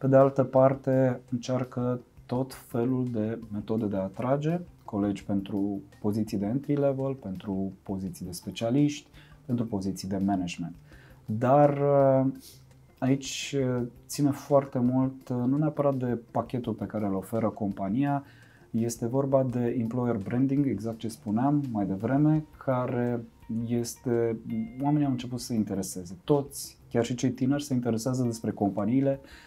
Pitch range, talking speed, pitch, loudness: 105-135 Hz, 135 wpm, 125 Hz, -28 LUFS